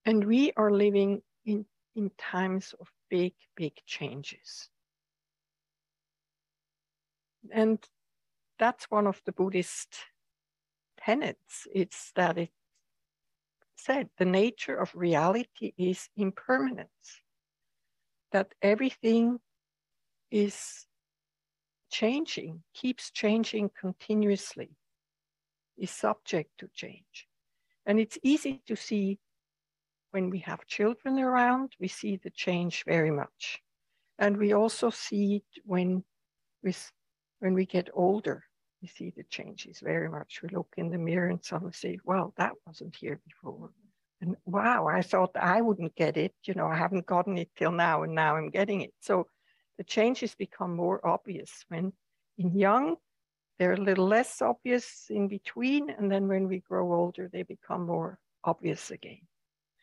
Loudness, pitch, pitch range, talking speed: -30 LUFS, 190 Hz, 175-215 Hz, 135 wpm